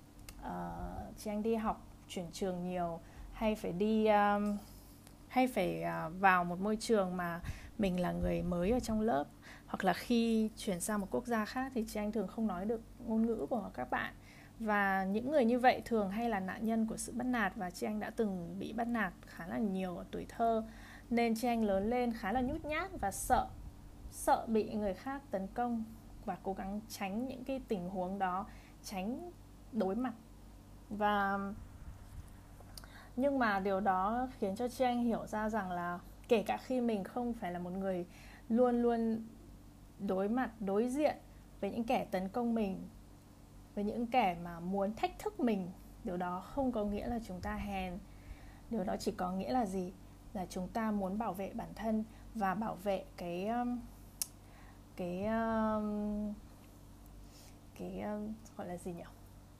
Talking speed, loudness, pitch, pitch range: 180 wpm, -36 LUFS, 205 Hz, 180-230 Hz